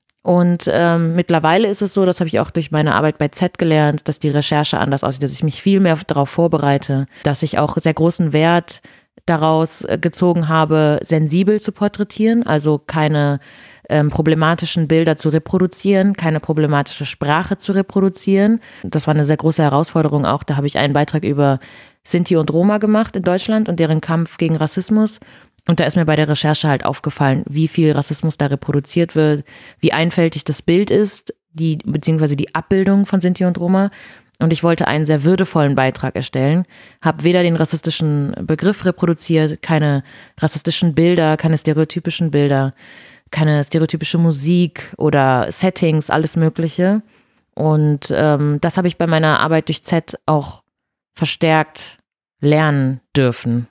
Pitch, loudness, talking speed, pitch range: 160 Hz, -16 LUFS, 160 wpm, 150-175 Hz